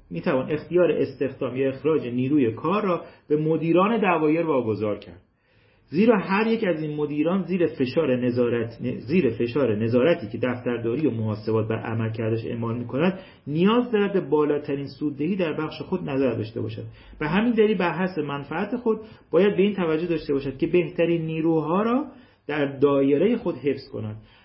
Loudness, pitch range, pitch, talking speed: -24 LUFS, 120-175 Hz, 150 Hz, 165 wpm